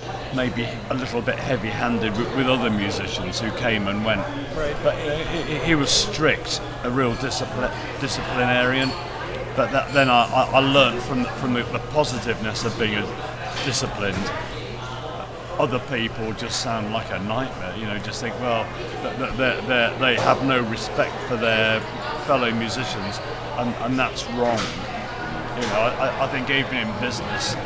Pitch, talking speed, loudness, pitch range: 125 Hz, 150 wpm, -23 LUFS, 115-130 Hz